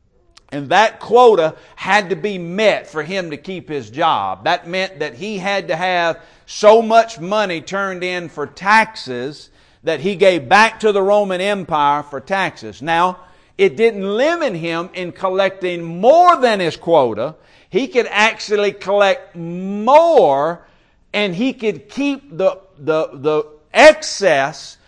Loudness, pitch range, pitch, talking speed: -16 LUFS, 165-210 Hz, 190 Hz, 145 wpm